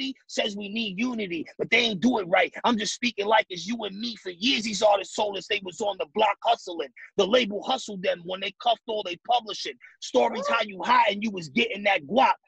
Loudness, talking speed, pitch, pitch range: -25 LUFS, 240 wpm, 215 Hz, 200-240 Hz